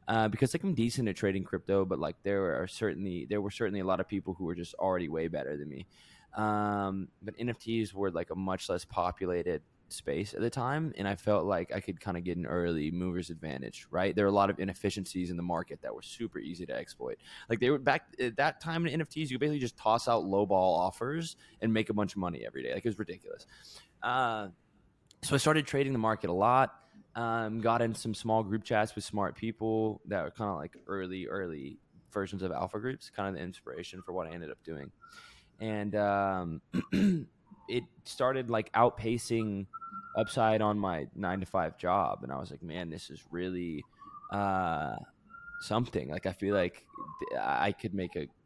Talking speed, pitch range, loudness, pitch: 210 wpm, 95-120 Hz, -33 LUFS, 105 Hz